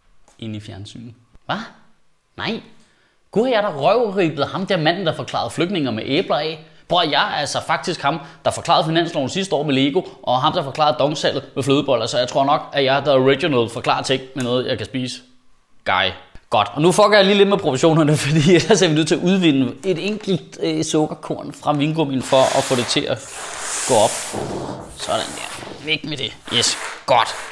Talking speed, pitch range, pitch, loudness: 205 wpm, 130-170 Hz, 150 Hz, -18 LUFS